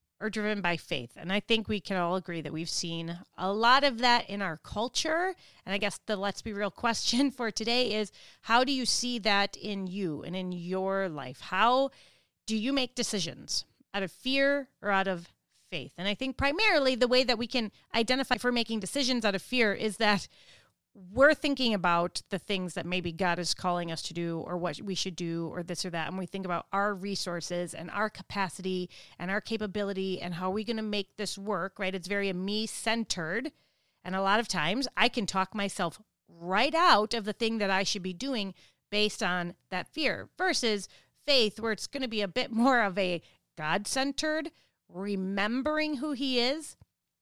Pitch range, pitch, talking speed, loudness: 180-240 Hz, 205 Hz, 205 wpm, -30 LUFS